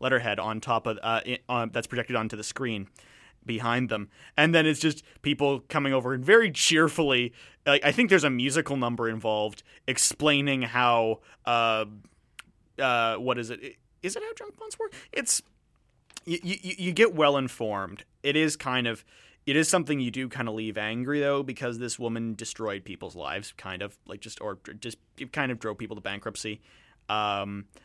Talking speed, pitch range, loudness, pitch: 180 wpm, 110-145 Hz, -27 LUFS, 125 Hz